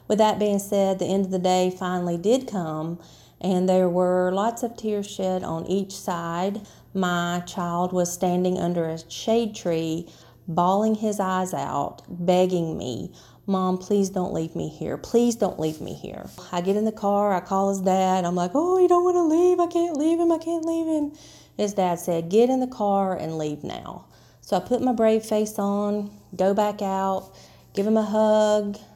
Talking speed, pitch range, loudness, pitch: 200 wpm, 180-215 Hz, -24 LUFS, 195 Hz